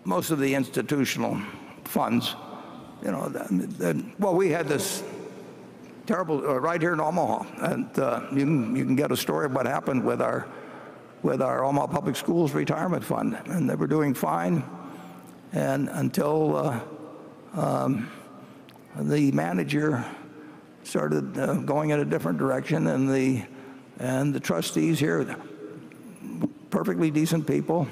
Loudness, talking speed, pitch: -26 LUFS, 145 wpm, 135 Hz